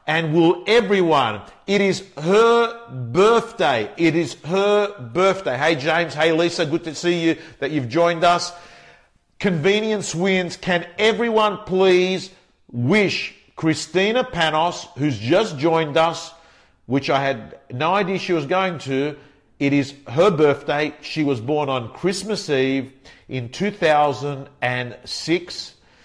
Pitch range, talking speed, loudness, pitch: 145-185 Hz, 130 wpm, -20 LUFS, 165 Hz